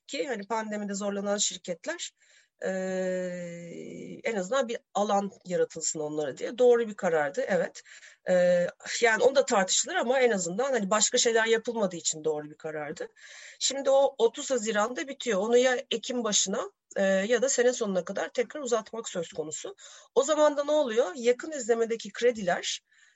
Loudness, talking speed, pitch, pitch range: -28 LUFS, 155 wpm, 230 Hz, 190-270 Hz